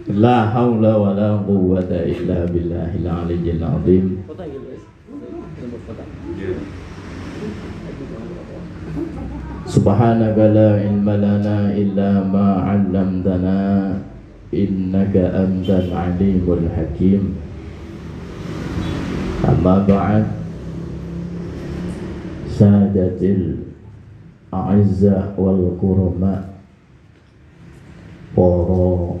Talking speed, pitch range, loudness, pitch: 50 wpm, 90-100 Hz, -17 LUFS, 95 Hz